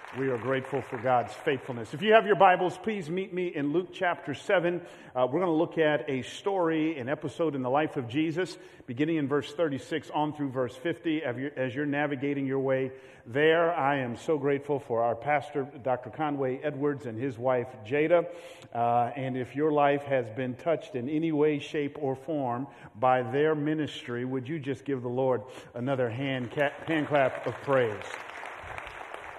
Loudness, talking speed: -29 LUFS, 185 wpm